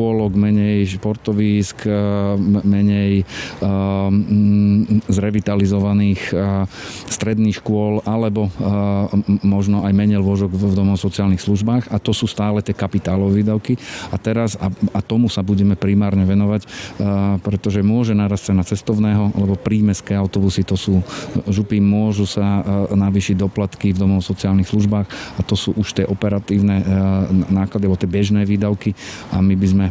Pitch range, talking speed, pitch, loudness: 100-105 Hz, 130 wpm, 100 Hz, -17 LUFS